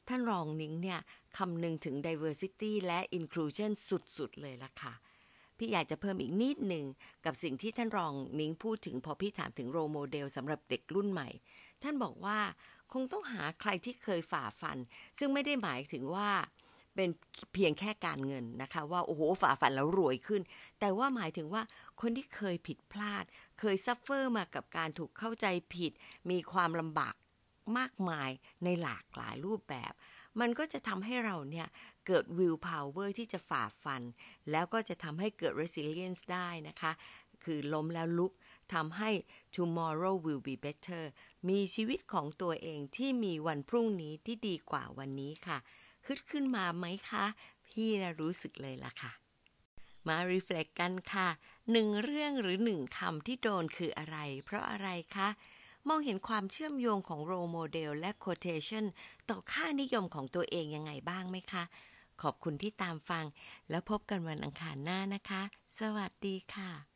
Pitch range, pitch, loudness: 155-210 Hz, 180 Hz, -38 LUFS